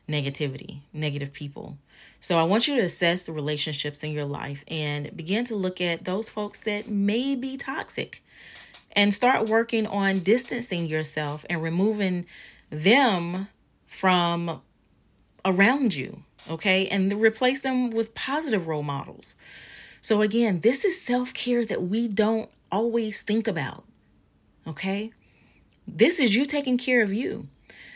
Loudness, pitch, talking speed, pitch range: -25 LUFS, 200 Hz, 140 wpm, 155-230 Hz